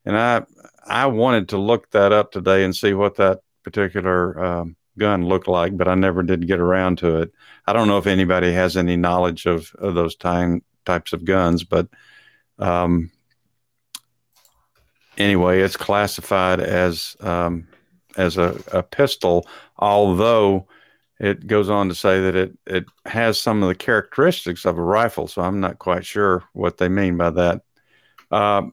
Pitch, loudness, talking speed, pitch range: 95 Hz, -19 LUFS, 165 wpm, 90-100 Hz